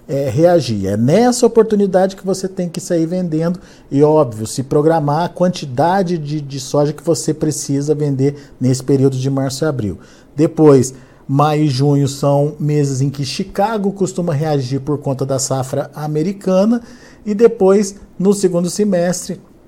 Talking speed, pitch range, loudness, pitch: 155 wpm, 140-185 Hz, -16 LUFS, 155 Hz